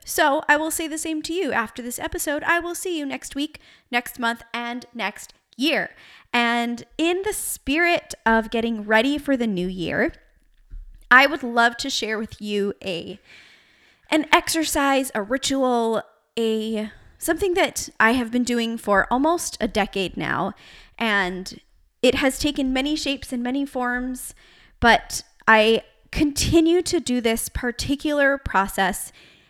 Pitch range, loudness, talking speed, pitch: 225-295 Hz, -22 LUFS, 150 wpm, 250 Hz